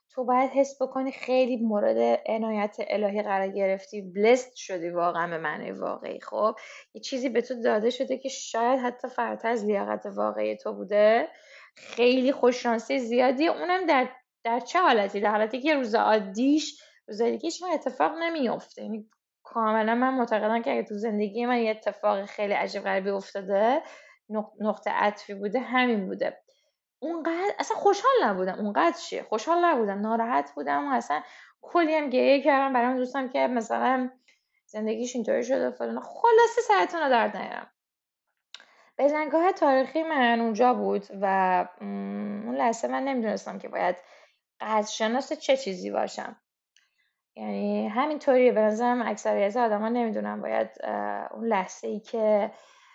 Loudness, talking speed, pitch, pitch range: -26 LUFS, 145 wpm, 235 Hz, 205-270 Hz